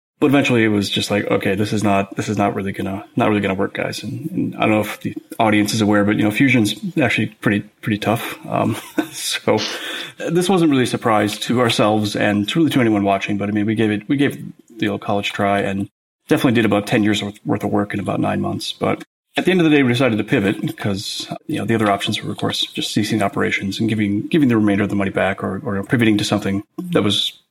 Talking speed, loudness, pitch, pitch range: 260 wpm, -18 LUFS, 105 Hz, 100-120 Hz